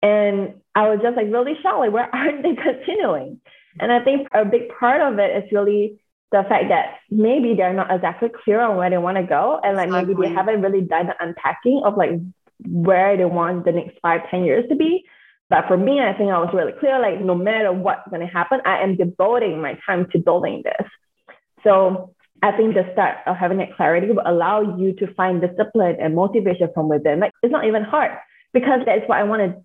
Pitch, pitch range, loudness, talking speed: 200 Hz, 180-235 Hz, -19 LUFS, 225 wpm